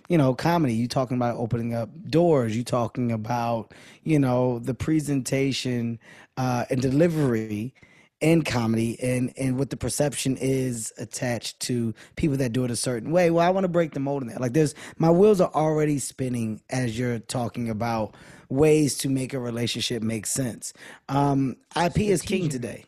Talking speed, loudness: 180 wpm, -25 LUFS